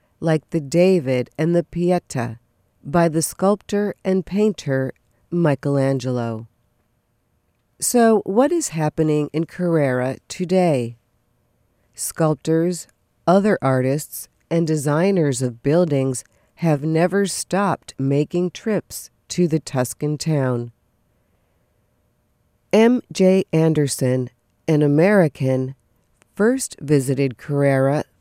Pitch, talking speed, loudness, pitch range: 150 Hz, 90 wpm, -20 LUFS, 130-175 Hz